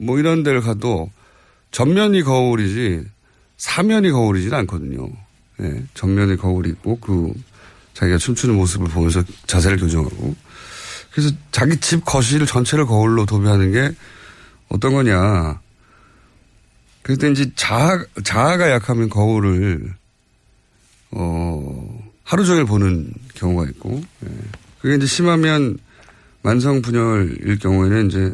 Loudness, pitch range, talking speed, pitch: -18 LUFS, 95-130 Hz, 265 characters per minute, 110 Hz